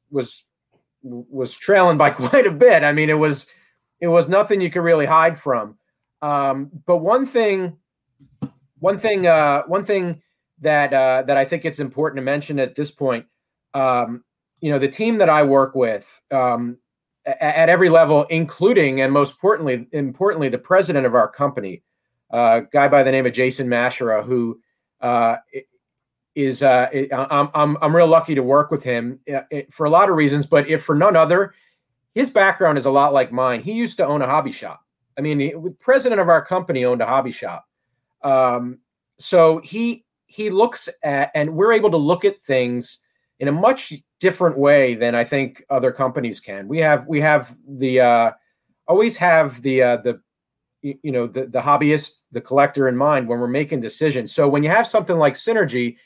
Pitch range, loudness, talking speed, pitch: 130-170 Hz, -18 LUFS, 190 wpm, 145 Hz